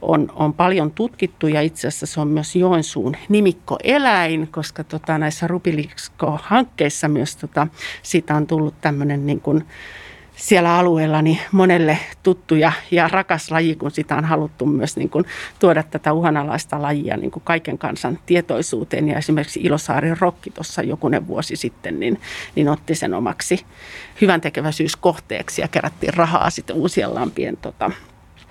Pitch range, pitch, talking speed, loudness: 150-175 Hz, 160 Hz, 140 wpm, -19 LUFS